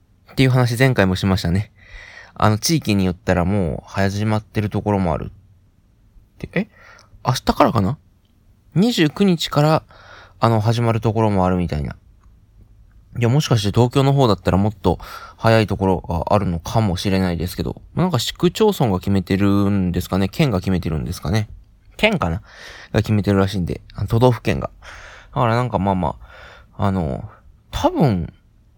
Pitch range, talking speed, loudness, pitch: 95-110 Hz, 330 characters per minute, -19 LUFS, 100 Hz